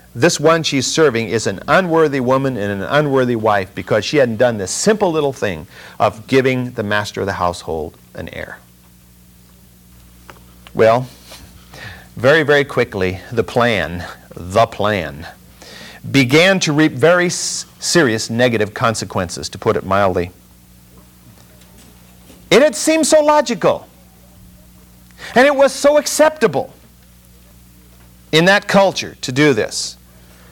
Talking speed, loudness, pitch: 130 wpm, -15 LUFS, 105 Hz